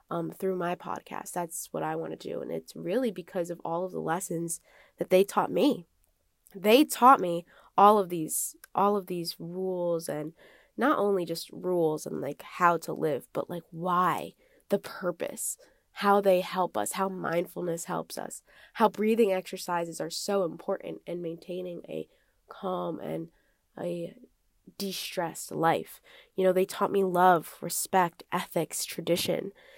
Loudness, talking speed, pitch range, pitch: -29 LUFS, 160 wpm, 170-200 Hz, 180 Hz